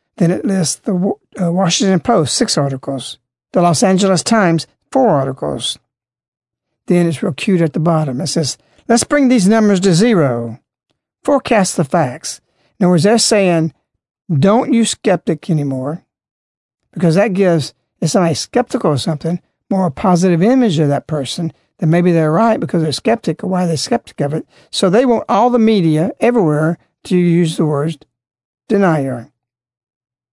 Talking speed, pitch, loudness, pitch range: 160 wpm, 170 Hz, -14 LUFS, 150-200 Hz